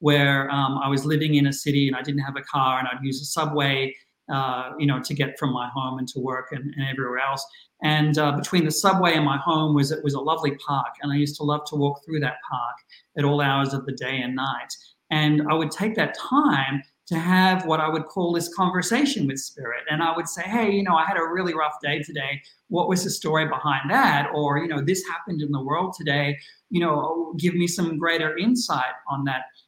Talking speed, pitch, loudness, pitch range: 245 wpm, 150 Hz, -23 LUFS, 140-165 Hz